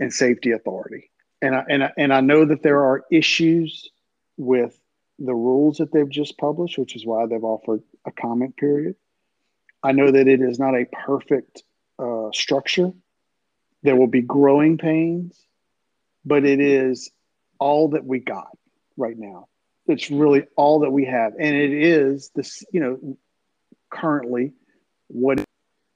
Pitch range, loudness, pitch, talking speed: 125-150 Hz, -20 LUFS, 140 Hz, 155 wpm